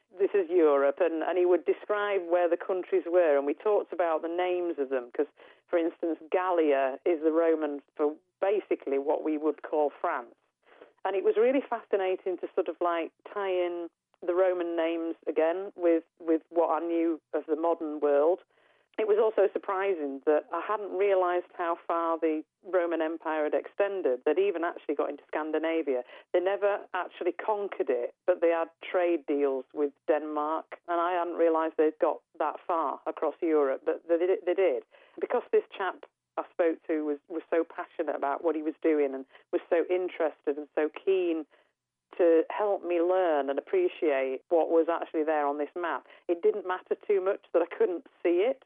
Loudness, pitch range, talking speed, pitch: -29 LUFS, 155-190 Hz, 185 wpm, 170 Hz